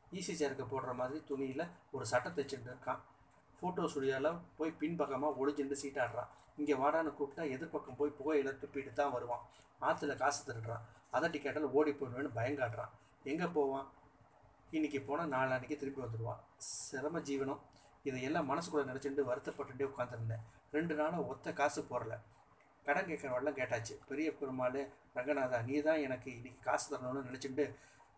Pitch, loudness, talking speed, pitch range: 140 Hz, -39 LUFS, 140 wpm, 130-150 Hz